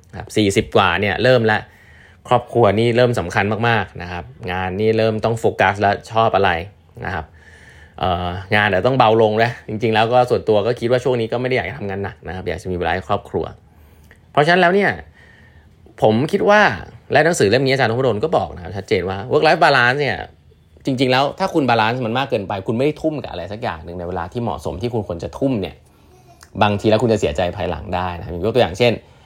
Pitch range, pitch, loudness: 90-120 Hz, 110 Hz, -18 LUFS